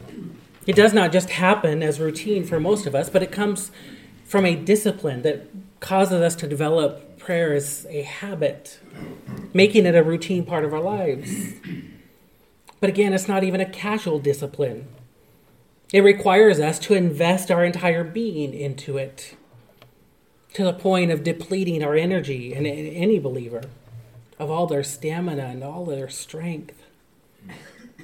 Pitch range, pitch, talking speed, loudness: 145-190 Hz, 165 Hz, 150 wpm, -21 LUFS